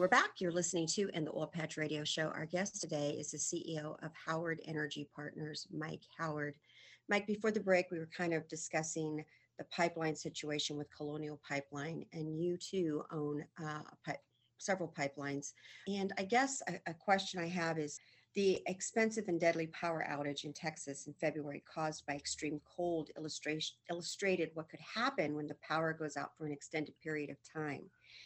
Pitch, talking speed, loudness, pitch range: 155 Hz, 175 wpm, -39 LUFS, 150-170 Hz